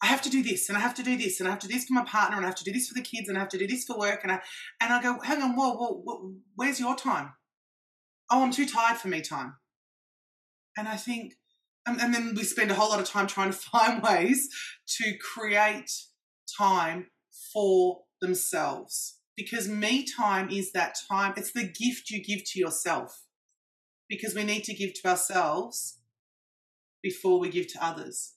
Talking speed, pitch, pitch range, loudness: 220 wpm, 210 Hz, 190-245 Hz, -28 LUFS